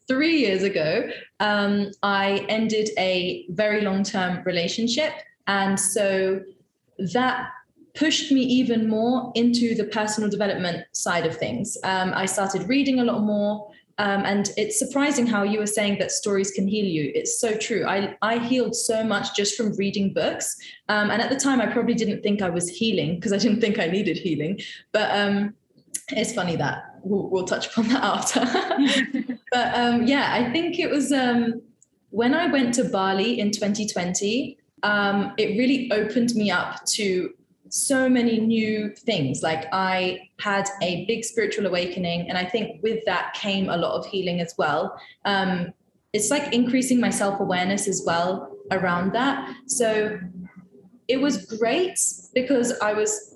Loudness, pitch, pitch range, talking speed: -23 LUFS, 210 Hz, 195-240 Hz, 165 wpm